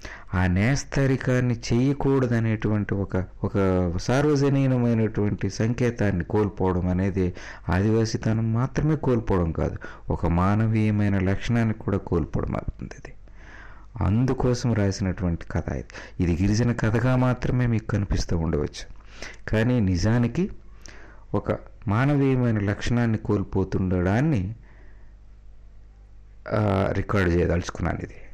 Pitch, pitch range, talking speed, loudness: 105 Hz, 95-120 Hz, 85 wpm, -24 LUFS